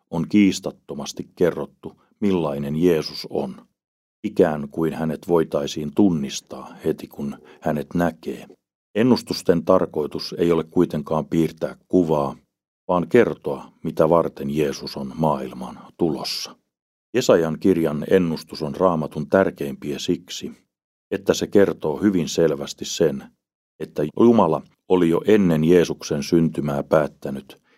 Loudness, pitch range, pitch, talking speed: -21 LUFS, 70-85 Hz, 80 Hz, 110 wpm